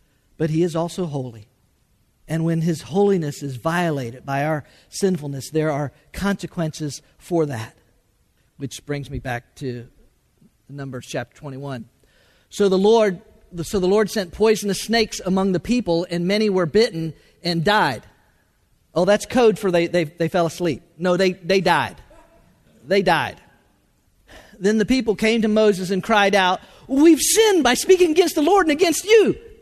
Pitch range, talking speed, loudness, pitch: 145-215 Hz, 160 wpm, -20 LUFS, 175 Hz